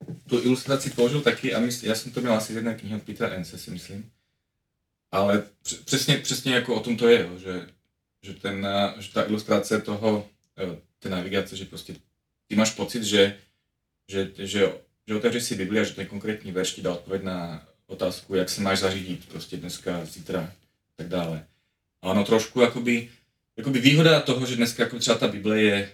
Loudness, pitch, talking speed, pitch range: -25 LUFS, 105 Hz, 185 wpm, 95-120 Hz